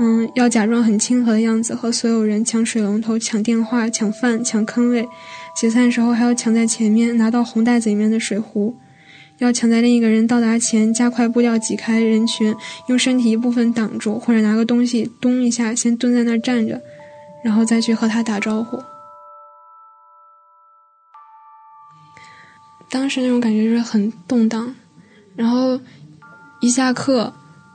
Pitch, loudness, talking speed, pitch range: 230 Hz, -17 LUFS, 245 characters per minute, 220-245 Hz